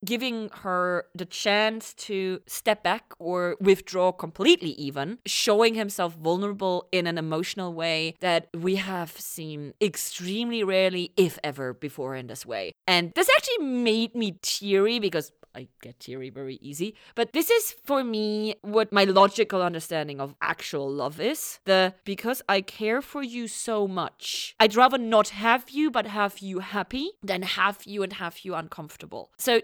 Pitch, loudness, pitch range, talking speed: 190 Hz, -26 LUFS, 170-220 Hz, 160 wpm